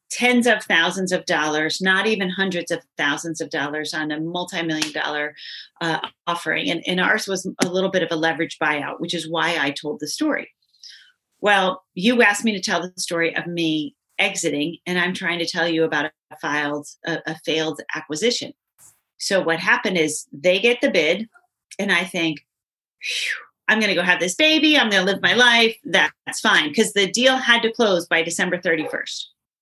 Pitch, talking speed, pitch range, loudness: 175 Hz, 190 wpm, 160-205 Hz, -20 LUFS